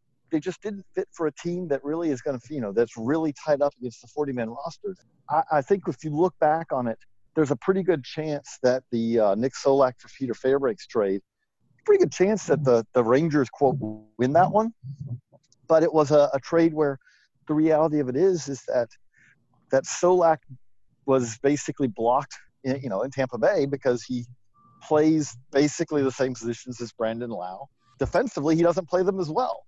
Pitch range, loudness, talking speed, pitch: 125-160 Hz, -25 LUFS, 200 wpm, 140 Hz